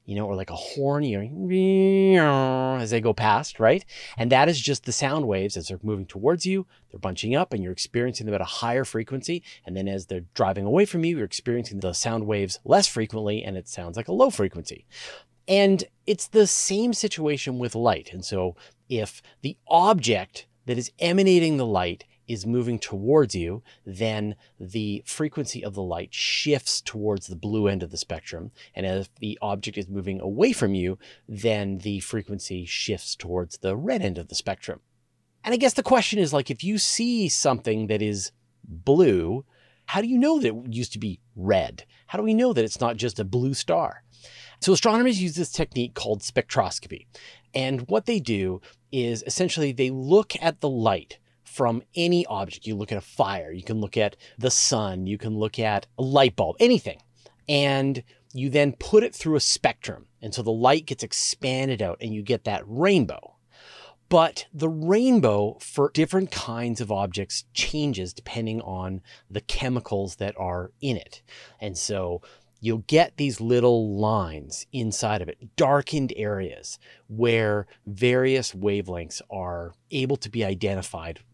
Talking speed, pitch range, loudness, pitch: 180 wpm, 100-145 Hz, -24 LUFS, 115 Hz